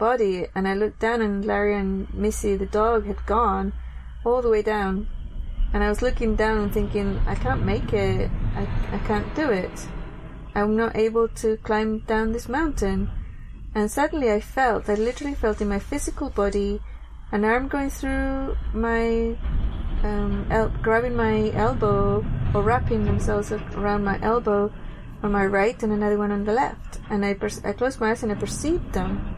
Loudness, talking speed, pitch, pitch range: -24 LUFS, 180 wpm, 210 Hz, 195-225 Hz